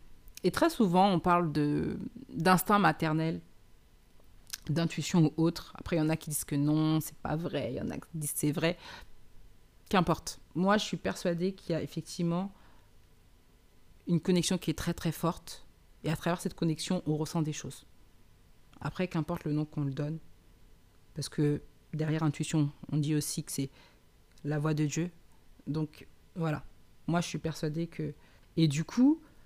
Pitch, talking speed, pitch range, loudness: 155 Hz, 175 wpm, 130-170 Hz, -32 LUFS